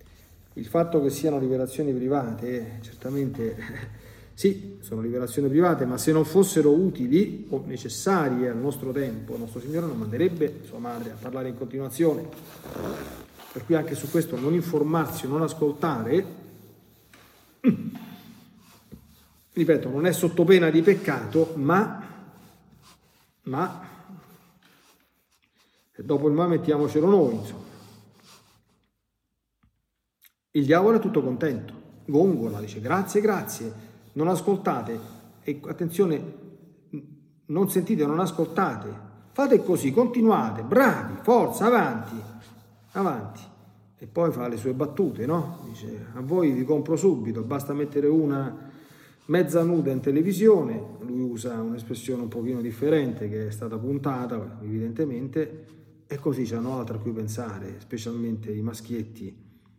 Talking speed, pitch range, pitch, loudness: 120 wpm, 115-170 Hz, 145 Hz, -25 LUFS